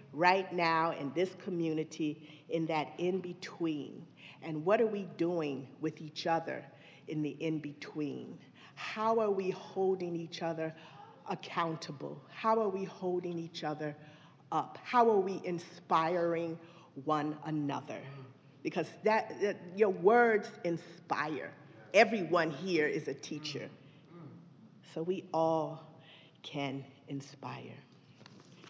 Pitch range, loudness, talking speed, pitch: 150-180 Hz, -34 LUFS, 120 wpm, 165 Hz